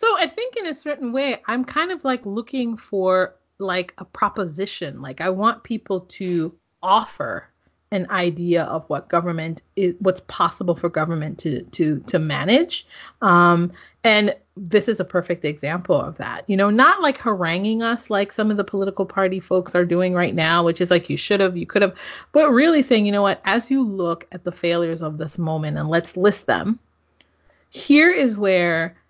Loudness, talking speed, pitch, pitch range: -20 LUFS, 190 wpm, 190 Hz, 175-230 Hz